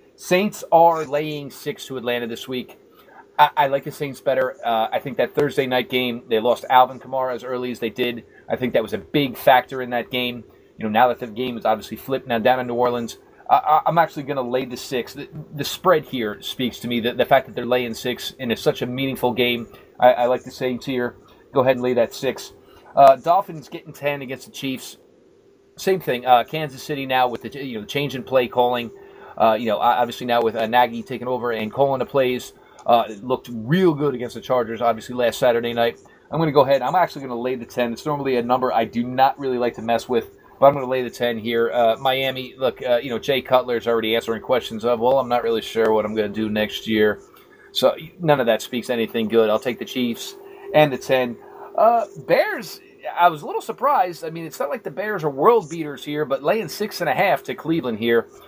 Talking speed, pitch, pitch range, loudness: 245 wpm, 125 Hz, 120-145 Hz, -21 LUFS